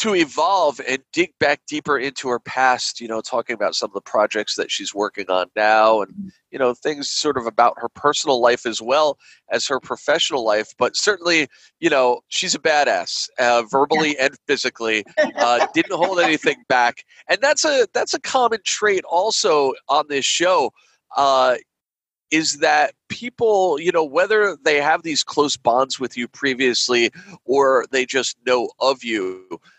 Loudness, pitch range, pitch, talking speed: -19 LUFS, 120-185 Hz, 135 Hz, 175 wpm